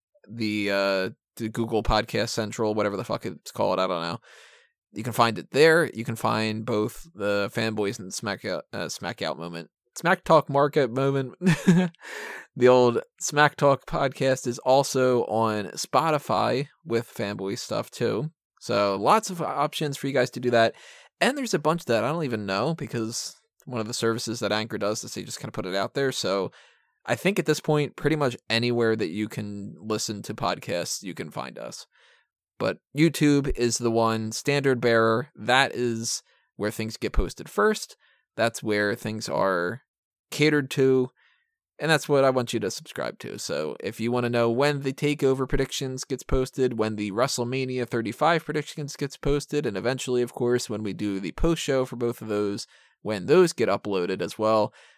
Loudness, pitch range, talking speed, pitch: -25 LUFS, 110-145 Hz, 190 wpm, 125 Hz